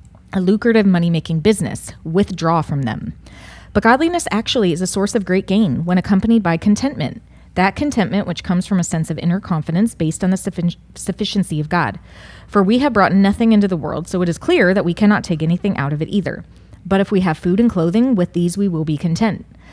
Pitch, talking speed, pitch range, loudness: 185 Hz, 220 wpm, 170-205 Hz, -17 LUFS